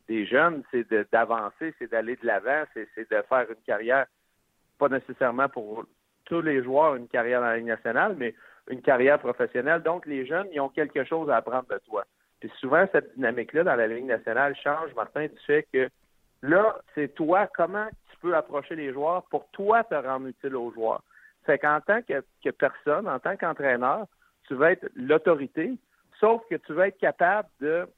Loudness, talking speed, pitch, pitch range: -26 LUFS, 195 wpm, 150 Hz, 130-180 Hz